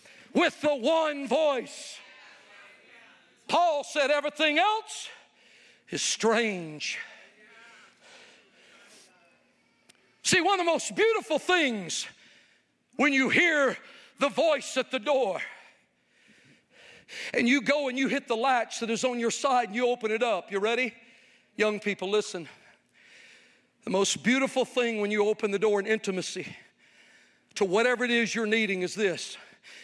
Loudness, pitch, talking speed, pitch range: -27 LUFS, 250 Hz, 135 wpm, 220-285 Hz